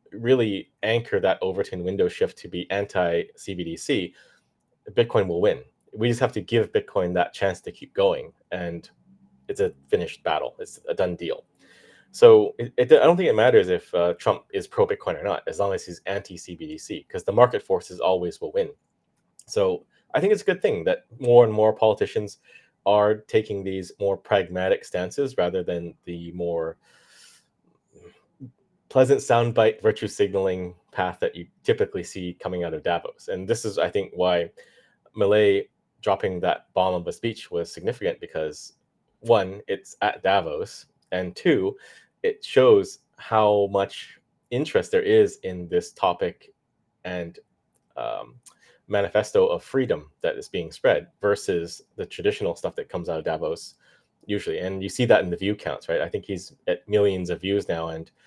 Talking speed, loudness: 170 wpm, -24 LUFS